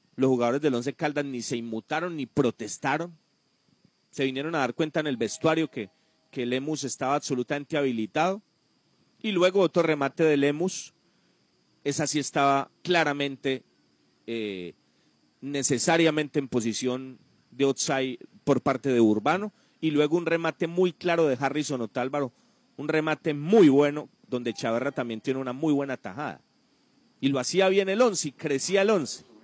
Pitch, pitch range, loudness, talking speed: 145 Hz, 130-160 Hz, -26 LUFS, 155 wpm